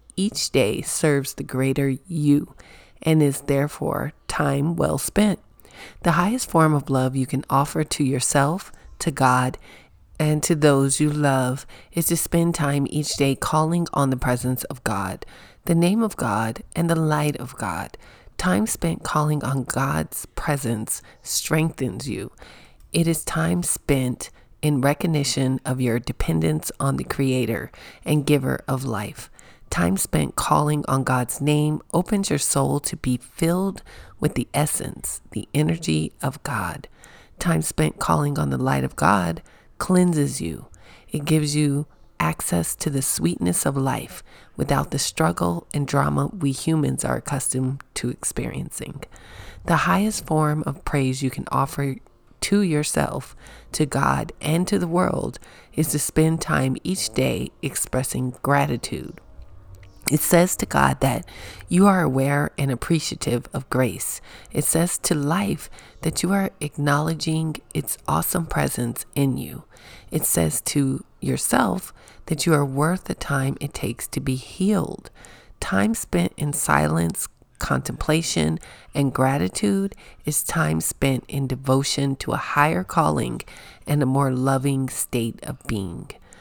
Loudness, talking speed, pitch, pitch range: -23 LUFS, 145 wpm, 140 Hz, 130-155 Hz